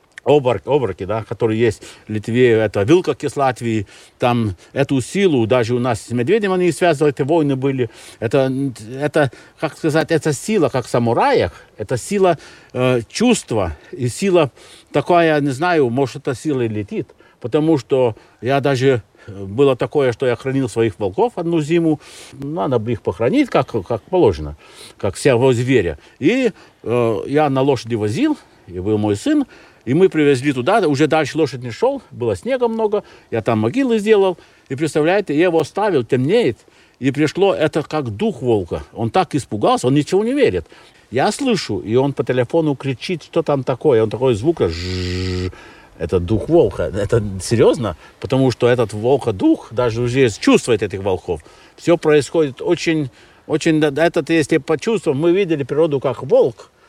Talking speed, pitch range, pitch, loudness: 160 wpm, 120-165 Hz, 140 Hz, -17 LUFS